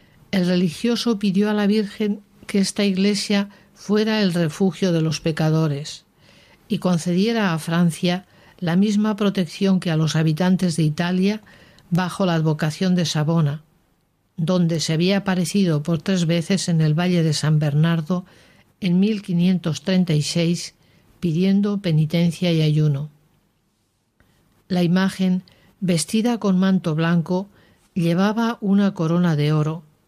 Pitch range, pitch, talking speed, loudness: 165-195 Hz, 180 Hz, 125 wpm, -20 LUFS